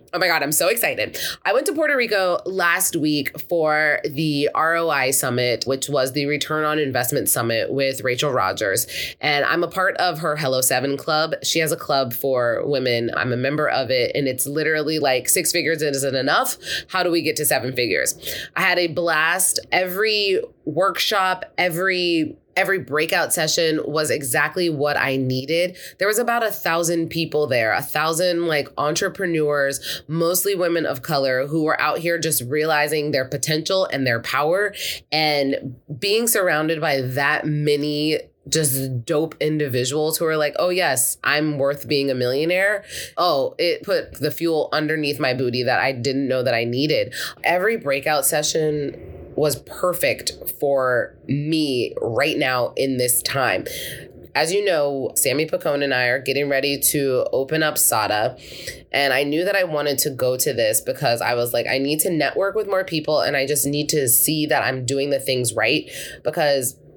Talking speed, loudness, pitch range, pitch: 175 wpm, -20 LUFS, 135-170 Hz, 150 Hz